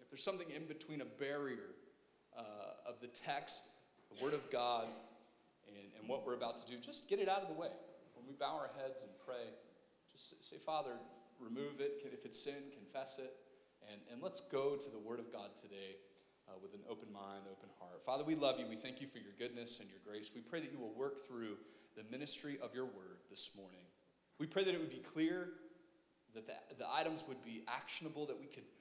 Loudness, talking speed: -45 LUFS, 225 wpm